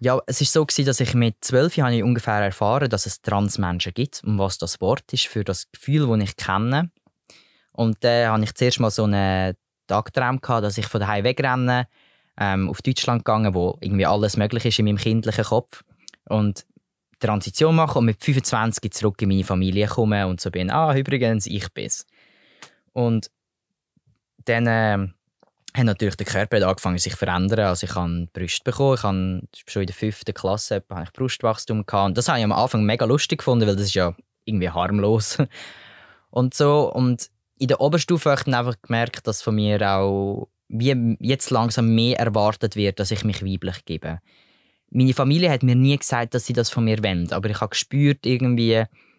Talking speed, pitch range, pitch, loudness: 195 wpm, 100-125 Hz, 110 Hz, -21 LUFS